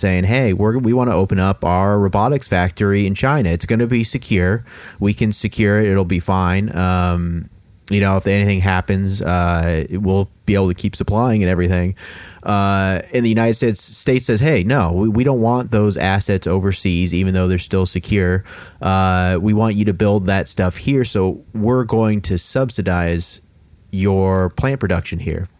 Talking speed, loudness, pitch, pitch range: 185 wpm, -17 LUFS, 100 Hz, 90-110 Hz